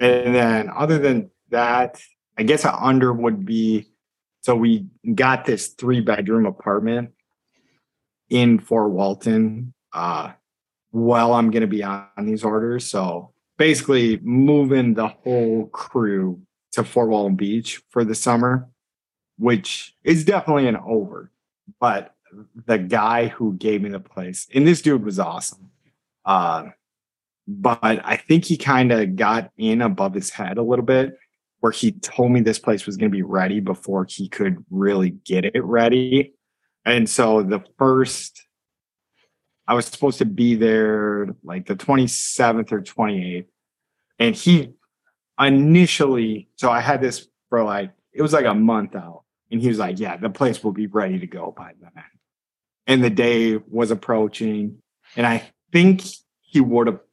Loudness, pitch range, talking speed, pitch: -20 LUFS, 110-130 Hz, 155 wpm, 115 Hz